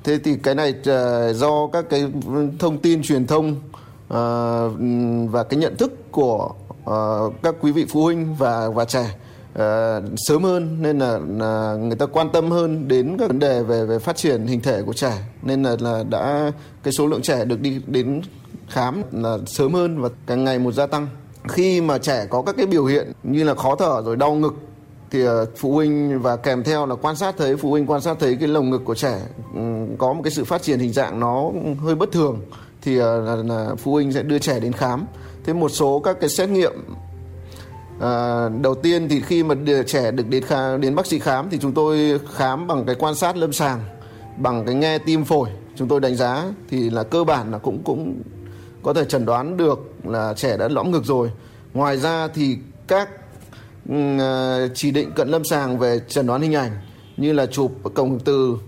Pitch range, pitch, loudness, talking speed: 120-150 Hz, 135 Hz, -20 LUFS, 205 wpm